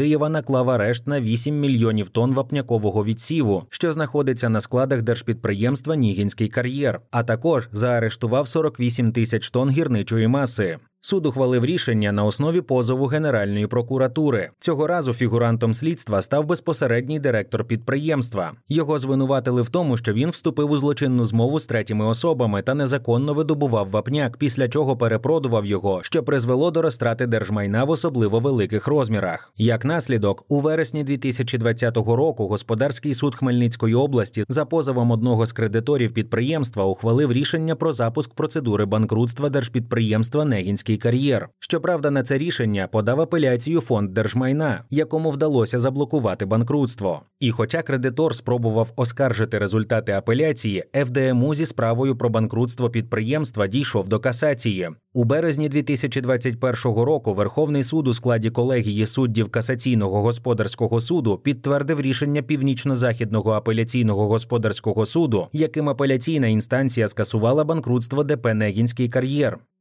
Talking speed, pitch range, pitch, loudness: 130 wpm, 115-145 Hz, 125 Hz, -21 LUFS